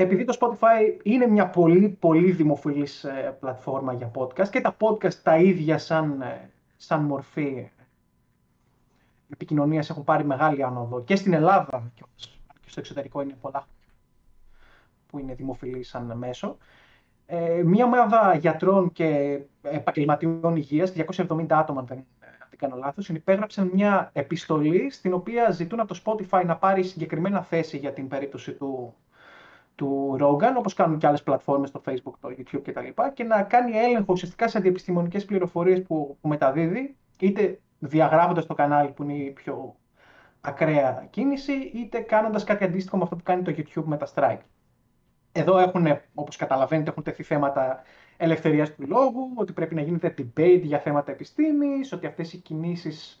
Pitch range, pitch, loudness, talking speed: 140-190 Hz, 160 Hz, -24 LUFS, 155 wpm